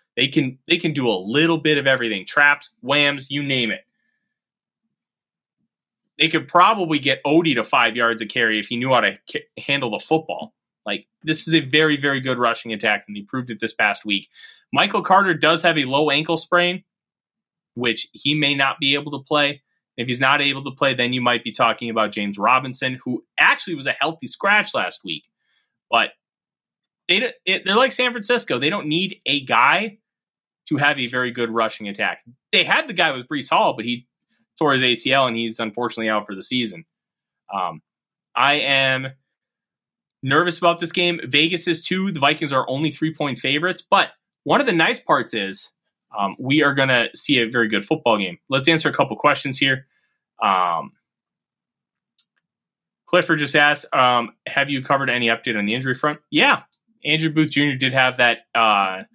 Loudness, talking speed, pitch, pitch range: -19 LUFS, 190 wpm, 140 Hz, 120-160 Hz